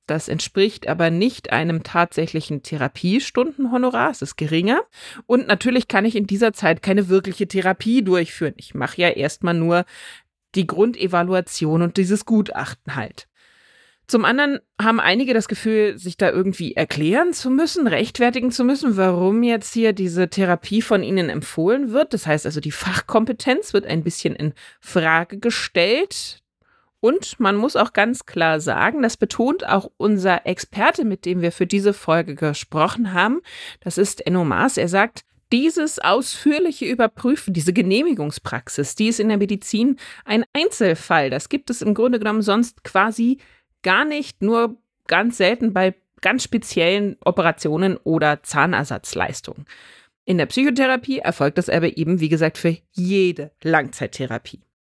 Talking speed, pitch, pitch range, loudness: 145 wpm, 200 Hz, 170-240 Hz, -20 LUFS